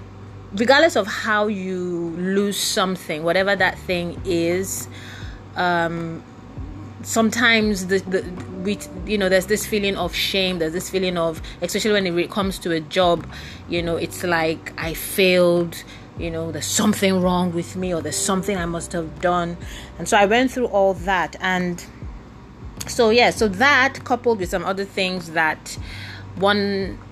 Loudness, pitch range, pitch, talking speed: -20 LUFS, 165-200 Hz, 180 Hz, 160 wpm